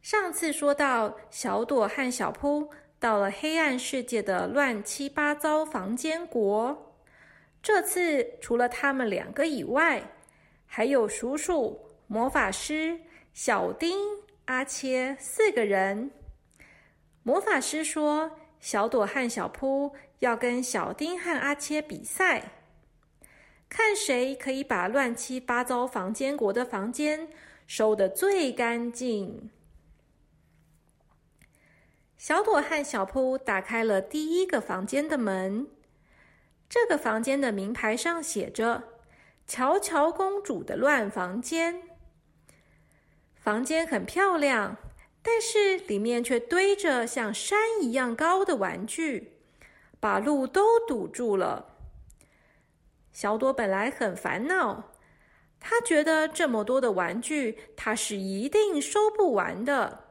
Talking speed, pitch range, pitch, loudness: 170 characters per minute, 225-320 Hz, 265 Hz, -27 LUFS